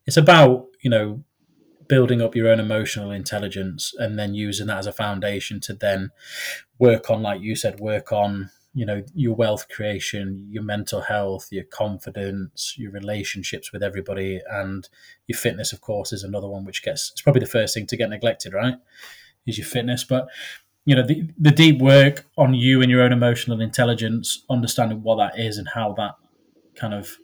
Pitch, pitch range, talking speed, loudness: 110 Hz, 100-125 Hz, 185 wpm, -21 LUFS